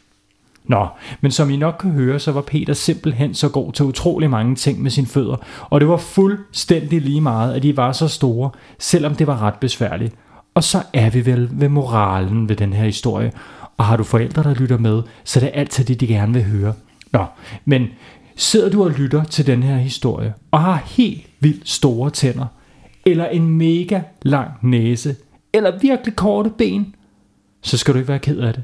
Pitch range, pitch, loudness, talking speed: 120-155 Hz, 140 Hz, -17 LUFS, 200 wpm